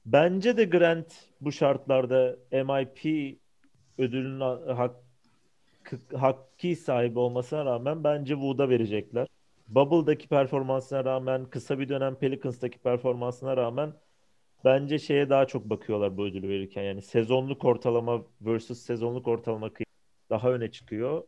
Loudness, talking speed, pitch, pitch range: -28 LUFS, 115 wpm, 130 Hz, 120-140 Hz